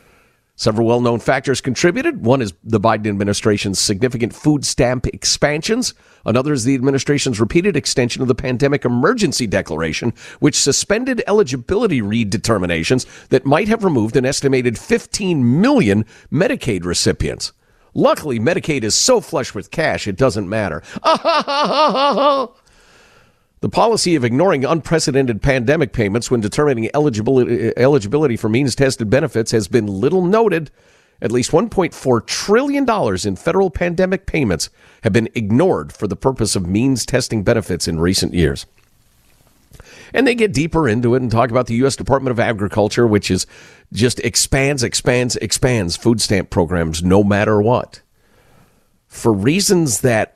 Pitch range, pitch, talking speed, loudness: 110-150 Hz, 125 Hz, 140 wpm, -16 LUFS